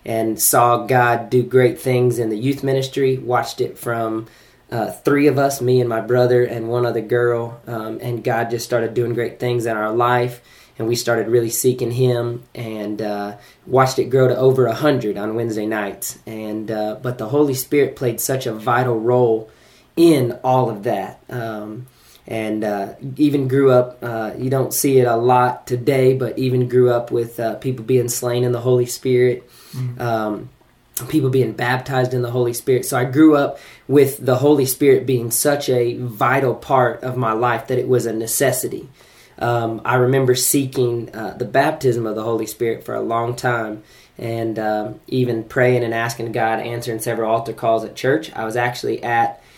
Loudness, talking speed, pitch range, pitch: -18 LUFS, 190 wpm, 115-130 Hz, 120 Hz